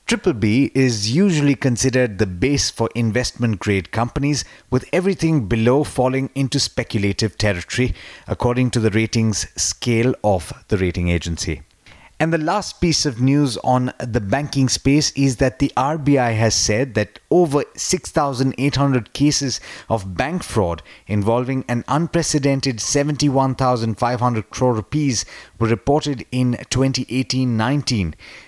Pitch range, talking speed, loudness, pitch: 110-140 Hz, 130 wpm, -19 LUFS, 125 Hz